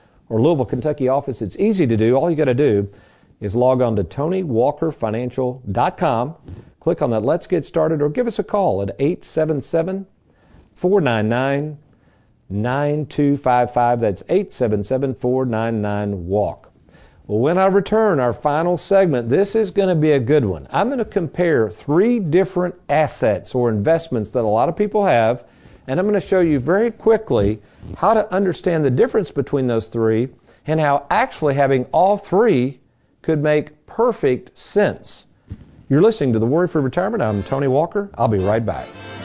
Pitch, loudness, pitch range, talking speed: 140 Hz, -18 LUFS, 115-180 Hz, 155 wpm